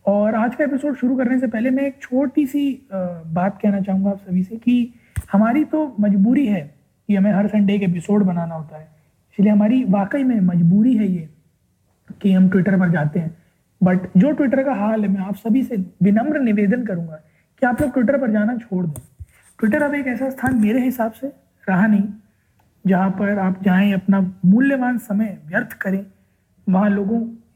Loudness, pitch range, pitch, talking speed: -19 LUFS, 185-245 Hz, 205 Hz, 185 wpm